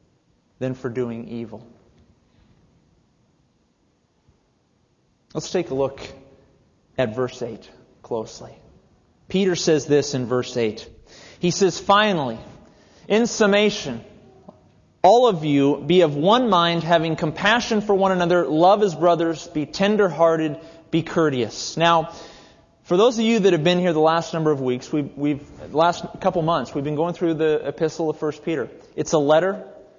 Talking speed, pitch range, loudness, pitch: 150 wpm, 140-180 Hz, -20 LUFS, 165 Hz